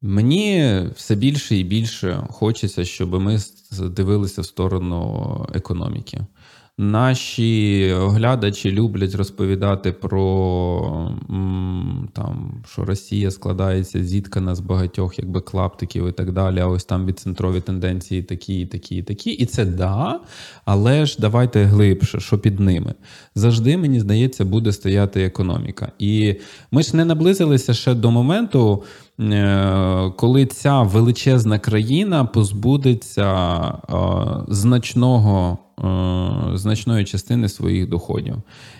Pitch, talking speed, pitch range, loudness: 105 Hz, 110 wpm, 95-120 Hz, -19 LUFS